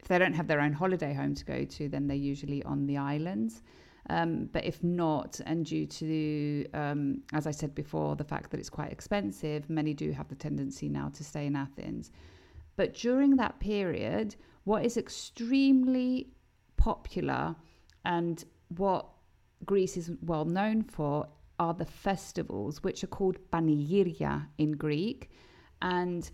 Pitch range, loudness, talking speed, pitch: 140-185 Hz, -32 LUFS, 160 wpm, 155 Hz